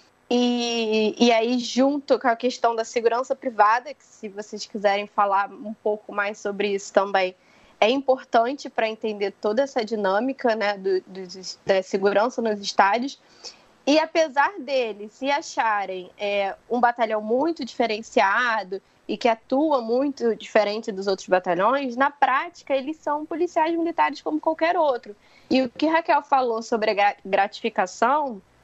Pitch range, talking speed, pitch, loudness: 205-270 Hz, 145 wpm, 230 Hz, -23 LUFS